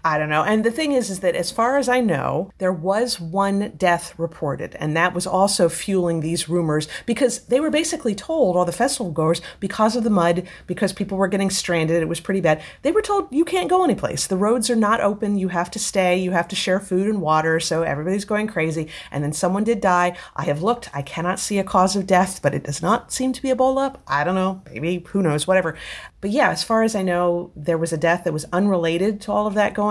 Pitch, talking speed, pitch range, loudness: 190 Hz, 255 wpm, 170-215 Hz, -20 LUFS